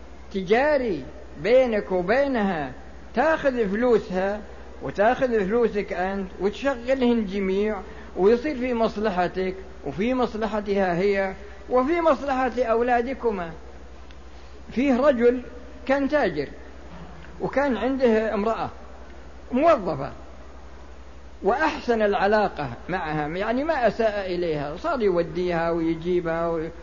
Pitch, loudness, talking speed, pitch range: 205 Hz, -24 LUFS, 85 wpm, 170-245 Hz